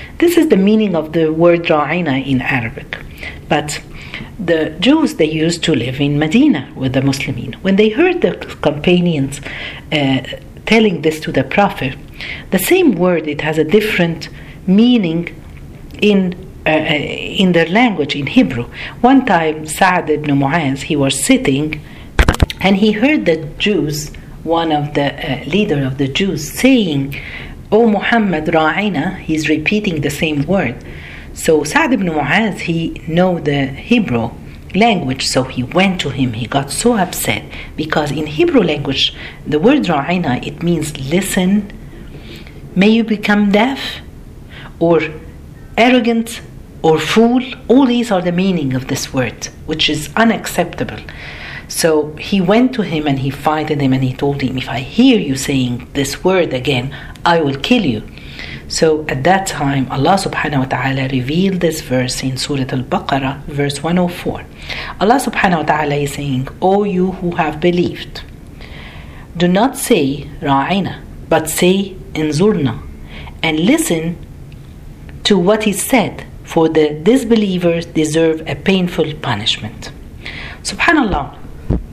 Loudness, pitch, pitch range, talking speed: -15 LUFS, 155 Hz, 140-195 Hz, 145 wpm